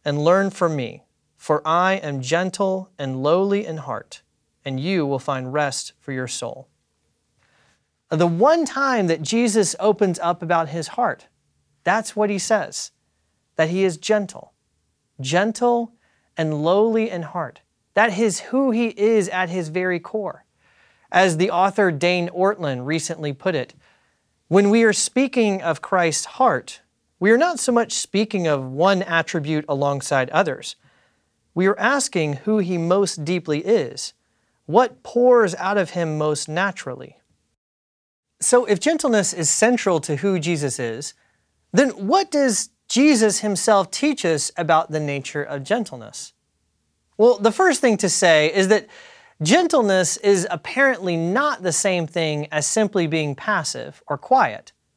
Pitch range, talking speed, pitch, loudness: 155-215 Hz, 145 wpm, 185 Hz, -20 LUFS